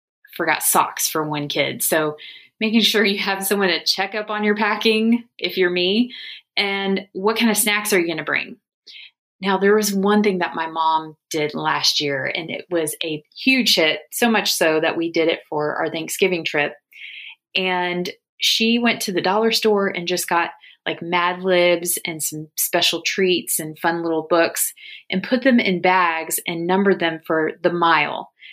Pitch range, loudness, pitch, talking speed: 165-210 Hz, -19 LUFS, 180 Hz, 190 wpm